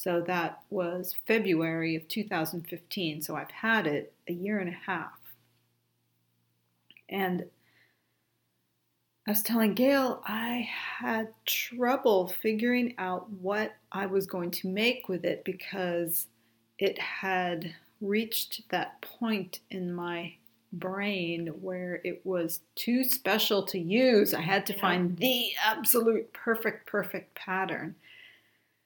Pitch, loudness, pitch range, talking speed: 185 Hz, -30 LUFS, 170-215 Hz, 120 wpm